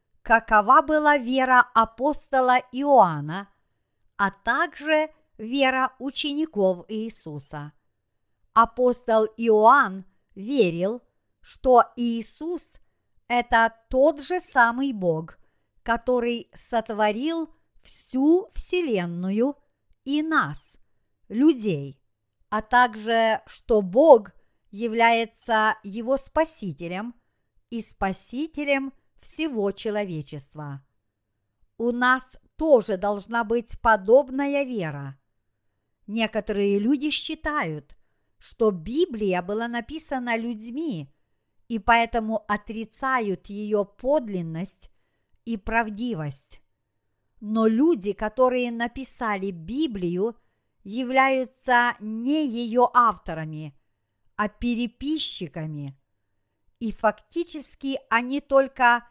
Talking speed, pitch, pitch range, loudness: 75 wpm, 225 Hz, 190-260 Hz, -23 LUFS